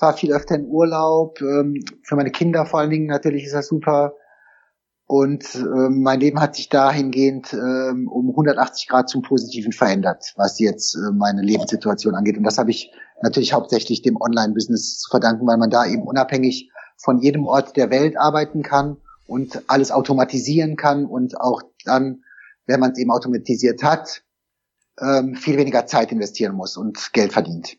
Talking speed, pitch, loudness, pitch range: 165 wpm, 135 Hz, -19 LUFS, 125-145 Hz